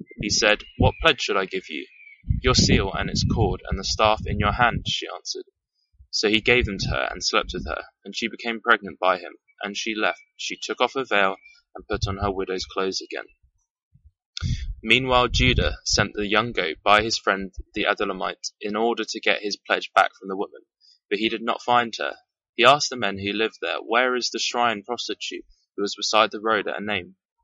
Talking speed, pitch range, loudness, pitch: 215 wpm, 100-125 Hz, -23 LUFS, 110 Hz